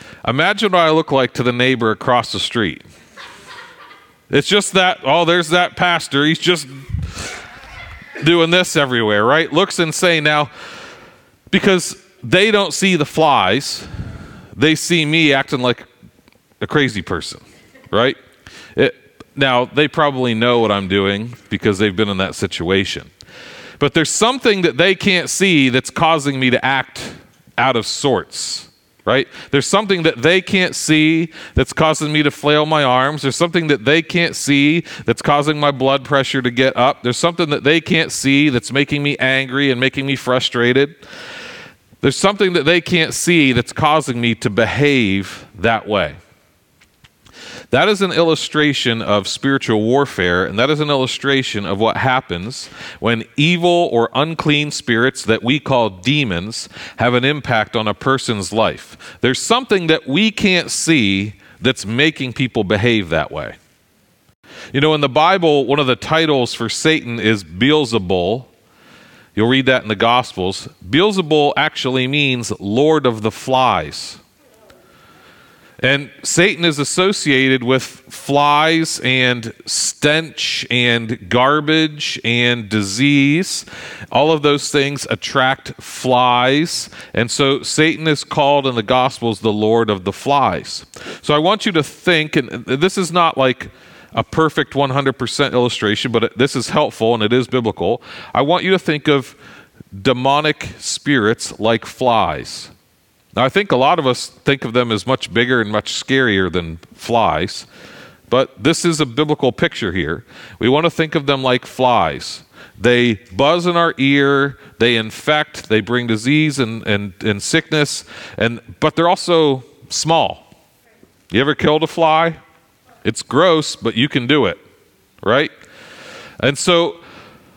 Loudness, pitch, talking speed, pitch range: -15 LUFS, 135 Hz, 155 wpm, 120-155 Hz